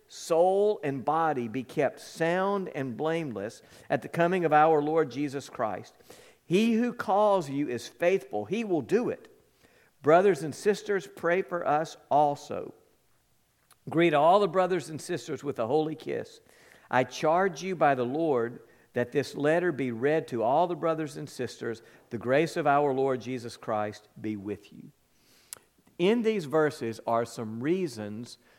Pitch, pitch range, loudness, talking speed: 155 Hz, 125-180 Hz, -28 LUFS, 160 wpm